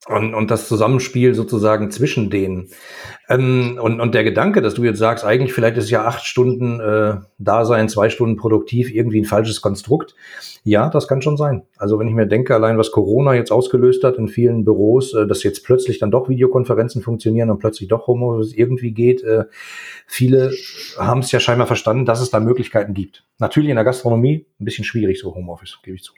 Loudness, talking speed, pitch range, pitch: -16 LUFS, 200 wpm, 110-125 Hz, 115 Hz